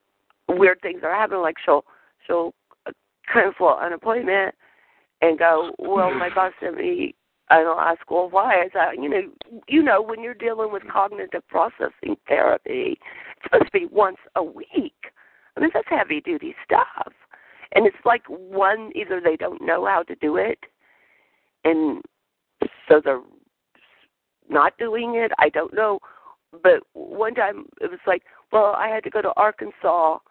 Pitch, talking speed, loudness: 220 Hz, 165 wpm, -21 LUFS